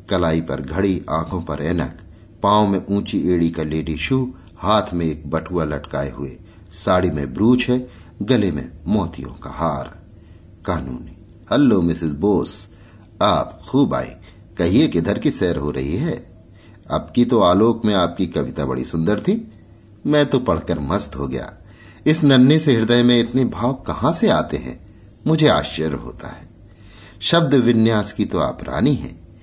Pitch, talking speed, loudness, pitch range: 95 Hz, 165 wpm, -19 LUFS, 80-110 Hz